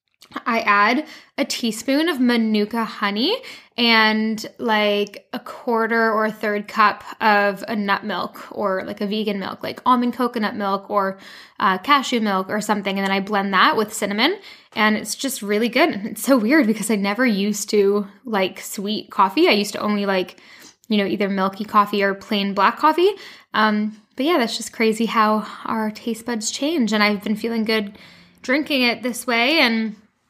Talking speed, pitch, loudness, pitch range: 185 wpm, 220 Hz, -20 LUFS, 205-240 Hz